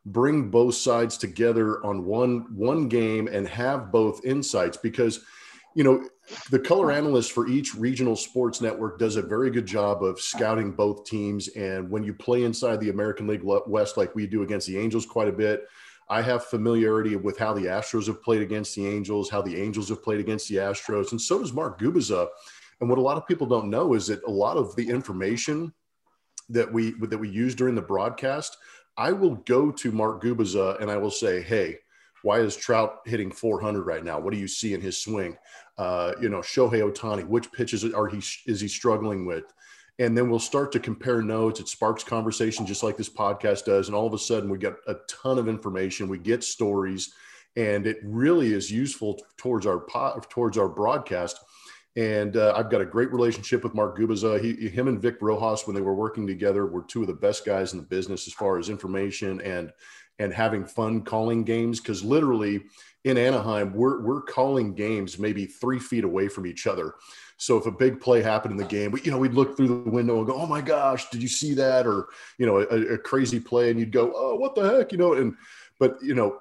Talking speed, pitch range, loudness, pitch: 215 wpm, 105-120 Hz, -26 LUFS, 110 Hz